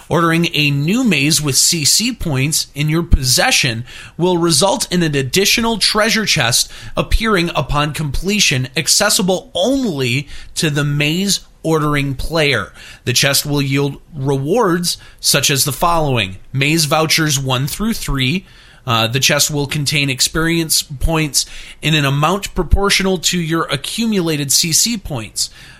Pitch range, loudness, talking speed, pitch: 140-175 Hz, -15 LUFS, 135 wpm, 155 Hz